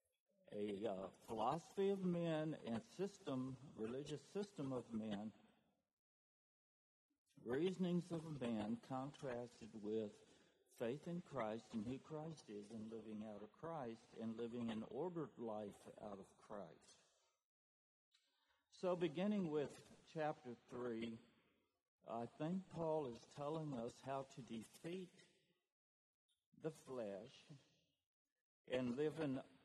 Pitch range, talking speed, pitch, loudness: 115-165 Hz, 110 wpm, 135 Hz, -48 LUFS